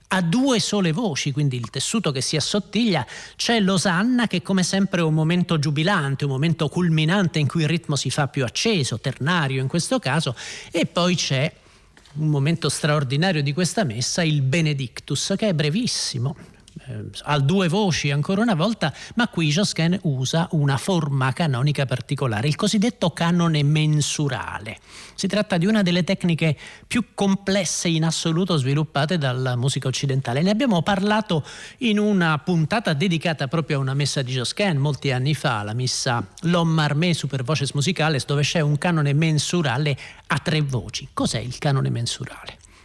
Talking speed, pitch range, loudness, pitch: 160 wpm, 140-180 Hz, -22 LUFS, 155 Hz